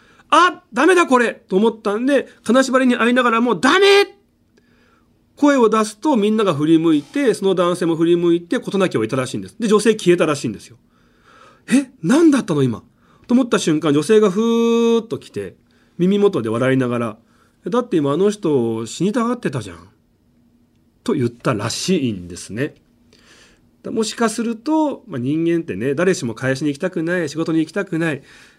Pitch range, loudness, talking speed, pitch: 140-230 Hz, -17 LUFS, 355 characters per minute, 185 Hz